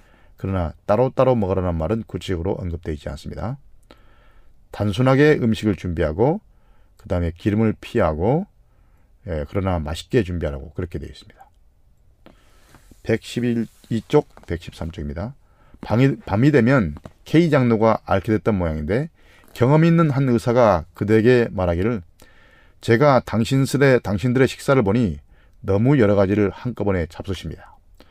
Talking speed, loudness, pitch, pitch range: 295 characters per minute, -20 LUFS, 105 Hz, 90-120 Hz